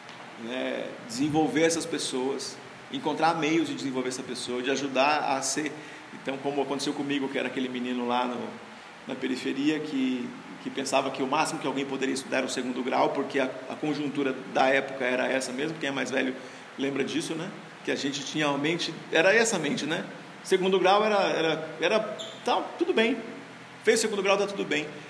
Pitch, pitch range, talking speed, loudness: 145 Hz, 135-165 Hz, 195 wpm, -28 LUFS